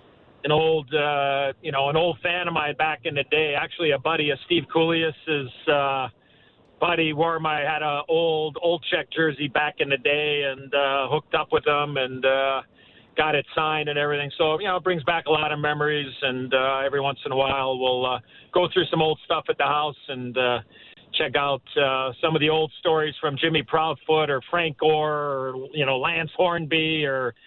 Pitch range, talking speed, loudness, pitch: 140-160 Hz, 210 wpm, -23 LUFS, 150 Hz